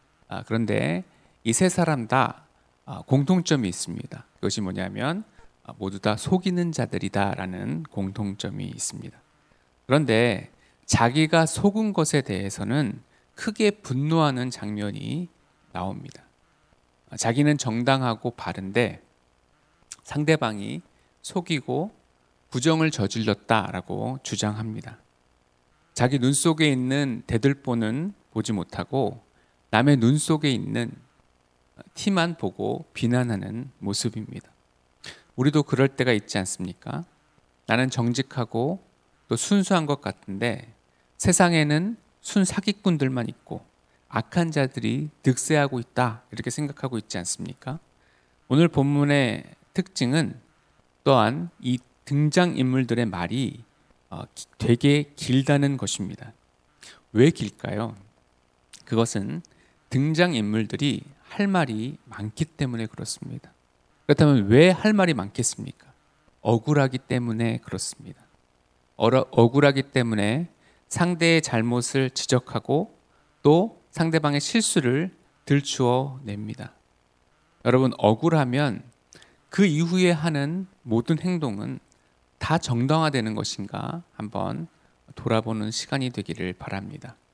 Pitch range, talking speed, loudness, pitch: 105-150 Hz, 240 characters per minute, -24 LUFS, 125 Hz